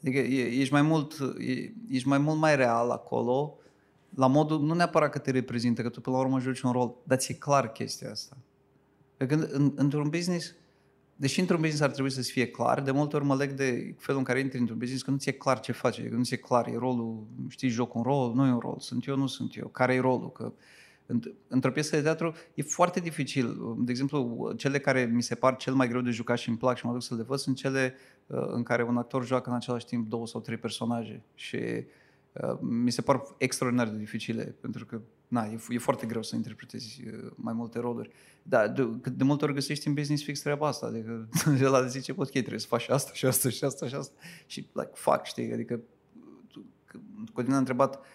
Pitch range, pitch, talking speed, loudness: 120-140 Hz, 130 Hz, 230 wpm, -29 LUFS